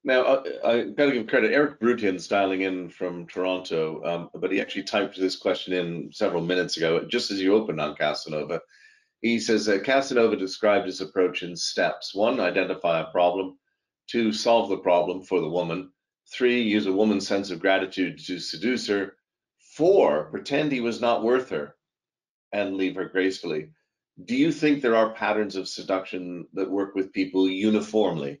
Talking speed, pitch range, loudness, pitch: 180 wpm, 90-115 Hz, -25 LUFS, 95 Hz